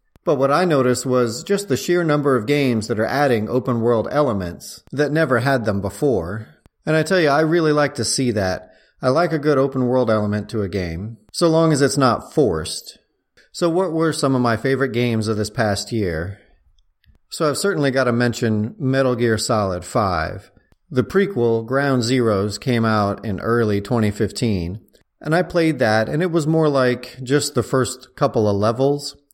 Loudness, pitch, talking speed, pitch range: -19 LUFS, 125 Hz, 190 wpm, 110-145 Hz